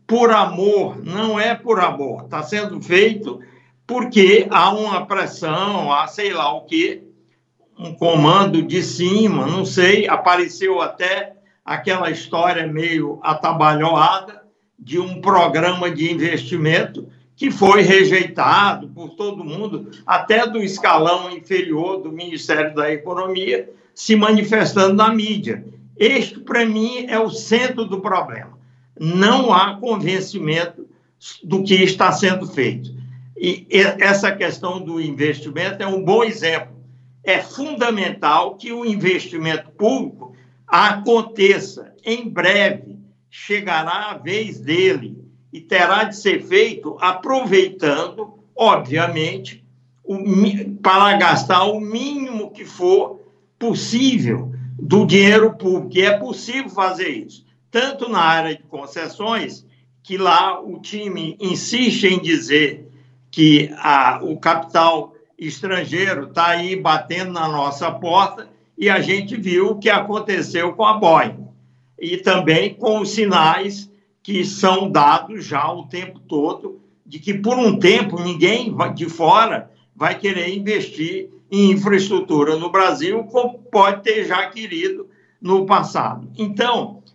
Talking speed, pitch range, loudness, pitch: 125 wpm, 165-215 Hz, -17 LUFS, 190 Hz